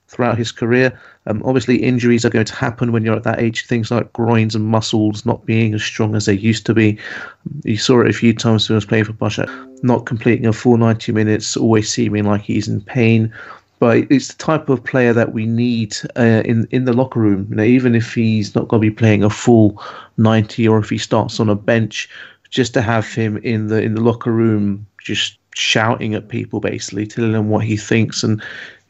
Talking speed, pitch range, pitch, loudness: 225 wpm, 110-120 Hz, 115 Hz, -16 LUFS